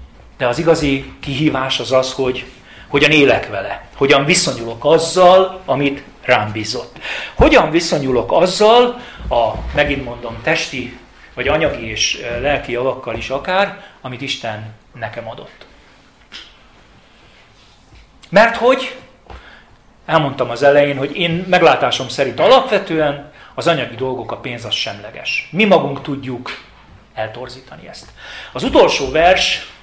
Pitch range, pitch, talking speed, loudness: 125-170 Hz, 140 Hz, 120 wpm, -15 LUFS